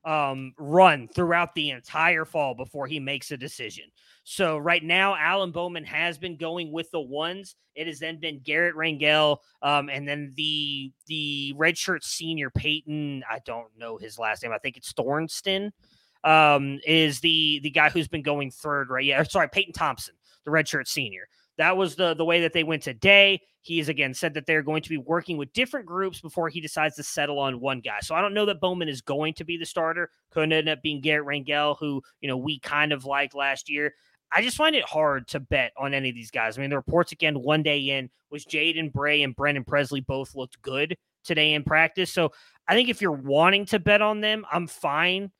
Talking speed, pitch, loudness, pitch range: 220 wpm, 155 Hz, -24 LUFS, 140-170 Hz